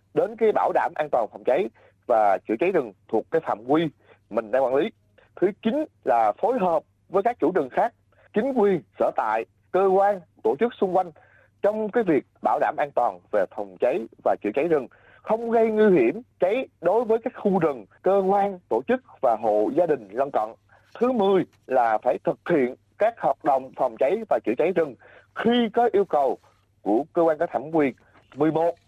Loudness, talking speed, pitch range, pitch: -24 LUFS, 210 wpm, 150-225 Hz, 195 Hz